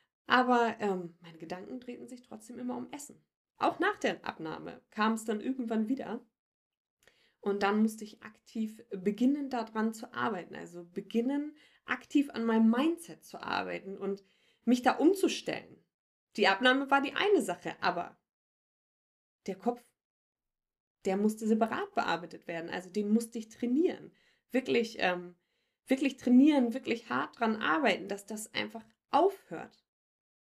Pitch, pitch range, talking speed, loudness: 235 Hz, 215-265 Hz, 140 wpm, -31 LUFS